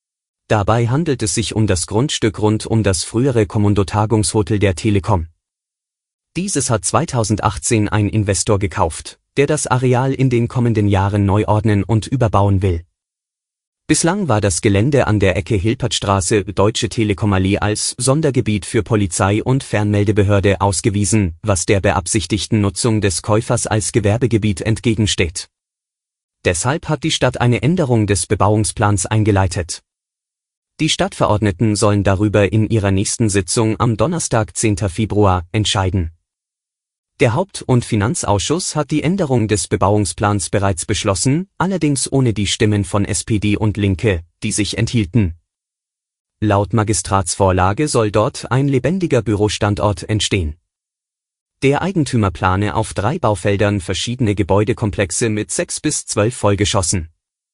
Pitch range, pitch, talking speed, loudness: 100-120 Hz, 105 Hz, 130 wpm, -16 LUFS